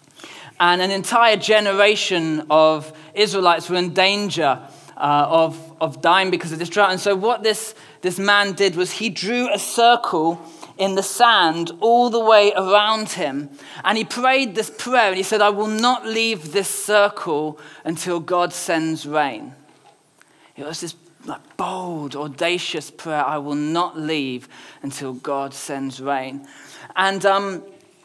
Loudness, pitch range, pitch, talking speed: -19 LUFS, 155-210 Hz, 180 Hz, 150 wpm